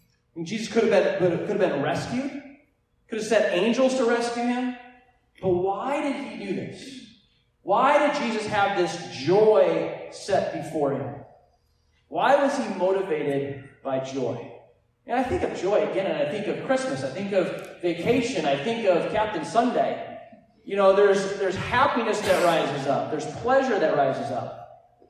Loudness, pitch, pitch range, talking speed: -24 LUFS, 210 Hz, 185-245 Hz, 165 wpm